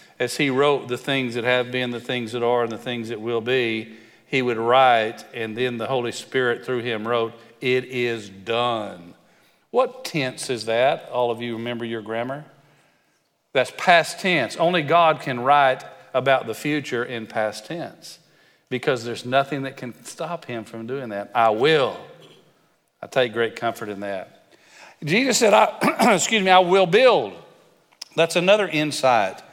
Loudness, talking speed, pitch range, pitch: -21 LUFS, 170 wpm, 115-145 Hz, 125 Hz